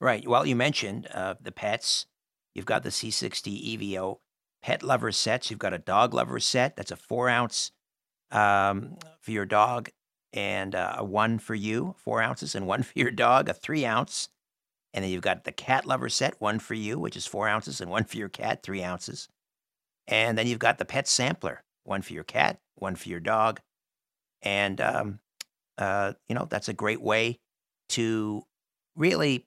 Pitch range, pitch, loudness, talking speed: 100-115 Hz, 105 Hz, -28 LUFS, 190 wpm